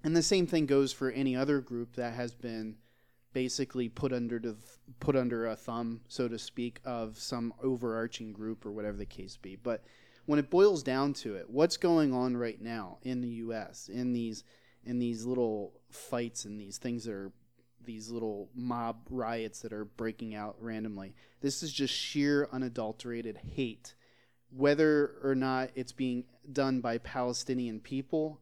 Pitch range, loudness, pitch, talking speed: 115-130 Hz, -34 LUFS, 120 Hz, 175 wpm